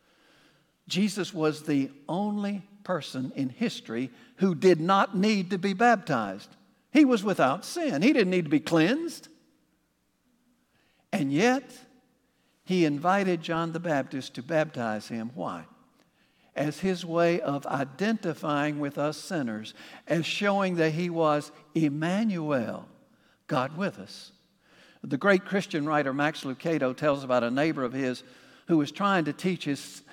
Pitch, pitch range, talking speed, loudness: 165 Hz, 145-200 Hz, 140 wpm, -27 LUFS